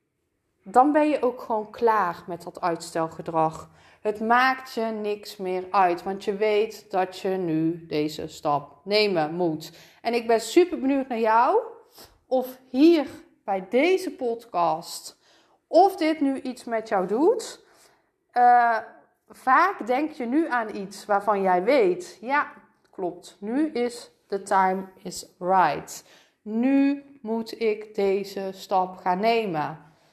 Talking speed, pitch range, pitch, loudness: 135 wpm, 185-260 Hz, 215 Hz, -24 LUFS